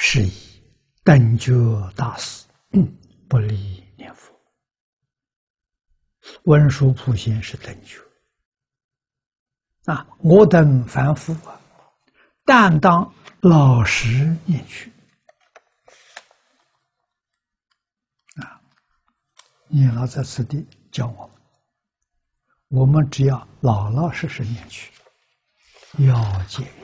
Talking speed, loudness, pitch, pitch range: 110 characters per minute, -17 LUFS, 130 Hz, 115-150 Hz